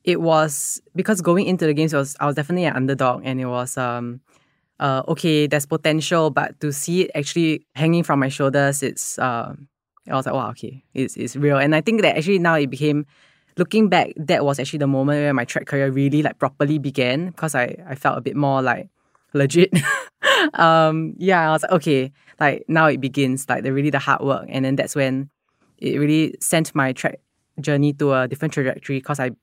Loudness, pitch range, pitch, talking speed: -20 LUFS, 135-160 Hz, 145 Hz, 215 wpm